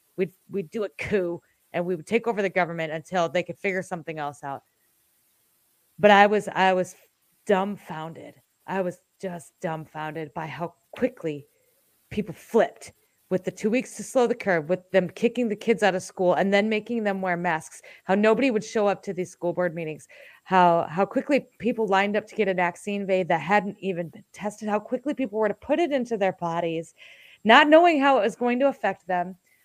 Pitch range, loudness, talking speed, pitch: 175-215 Hz, -24 LUFS, 200 wpm, 190 Hz